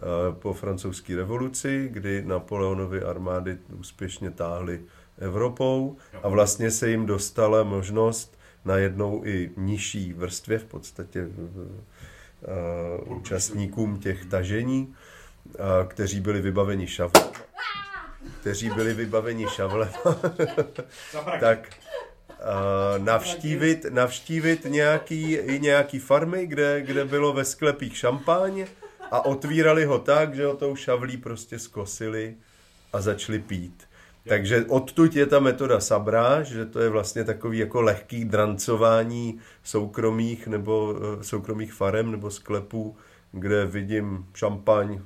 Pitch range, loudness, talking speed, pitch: 95-125 Hz, -25 LUFS, 115 wpm, 110 Hz